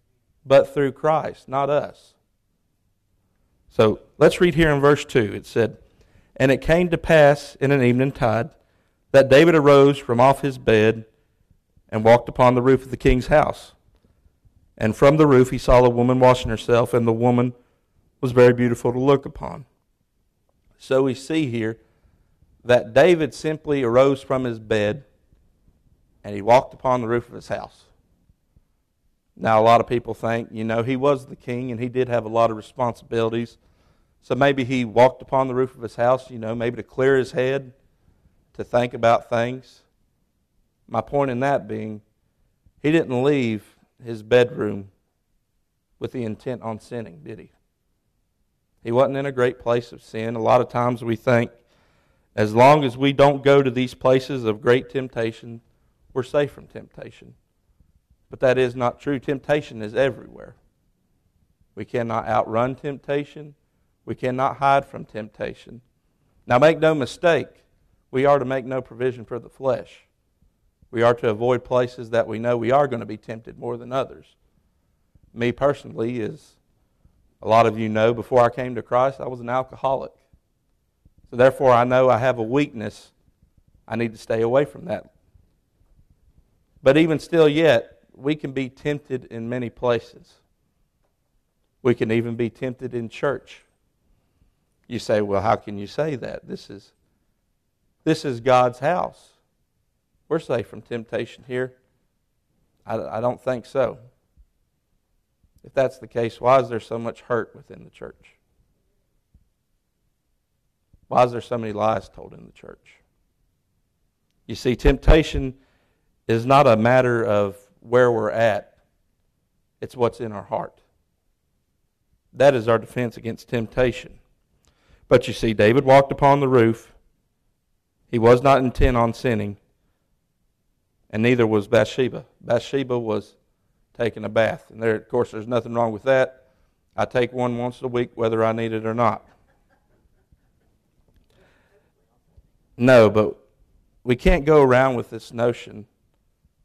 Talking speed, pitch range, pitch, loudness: 160 wpm, 110-130 Hz, 120 Hz, -20 LUFS